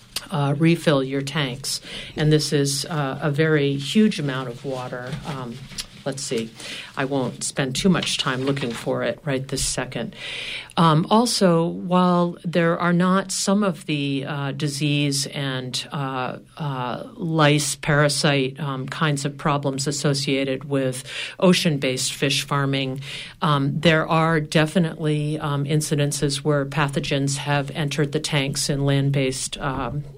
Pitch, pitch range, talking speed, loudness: 145 Hz, 135-160 Hz, 140 wpm, -22 LUFS